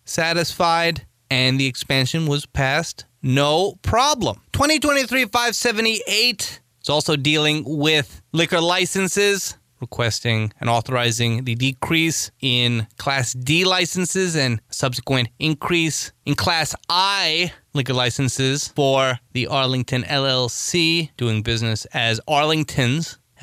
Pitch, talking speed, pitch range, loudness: 140 Hz, 105 wpm, 125-165 Hz, -19 LUFS